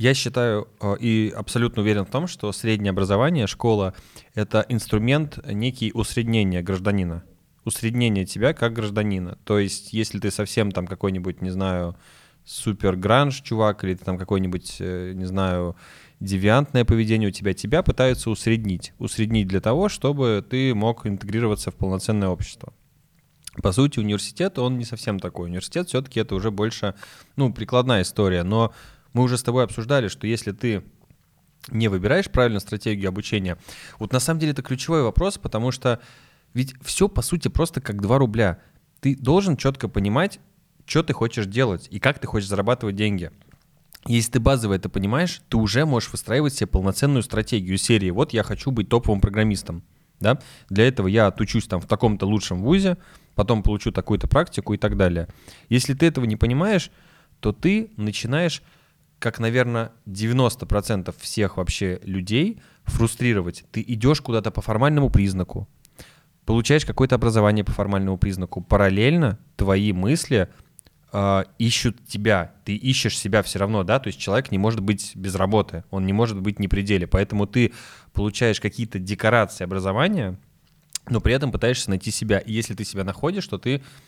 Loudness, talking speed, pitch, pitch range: -23 LUFS, 160 wpm, 110 Hz, 100-130 Hz